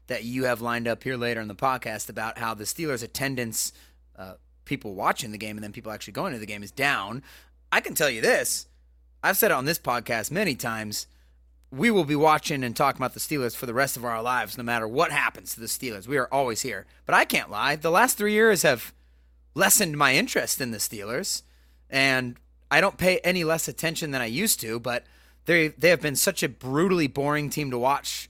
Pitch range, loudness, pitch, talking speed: 105-145 Hz, -25 LUFS, 120 Hz, 225 wpm